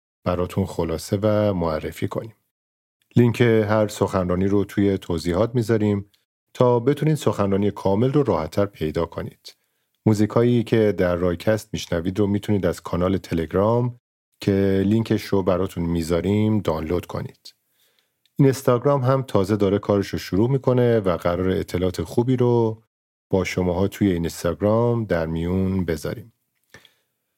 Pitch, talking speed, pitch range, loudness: 100 Hz, 130 wpm, 90-110 Hz, -22 LUFS